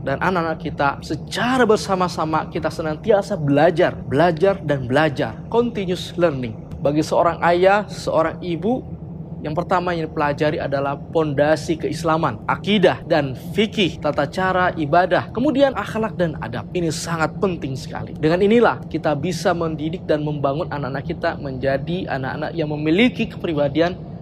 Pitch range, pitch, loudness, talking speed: 150-180 Hz, 165 Hz, -20 LUFS, 130 wpm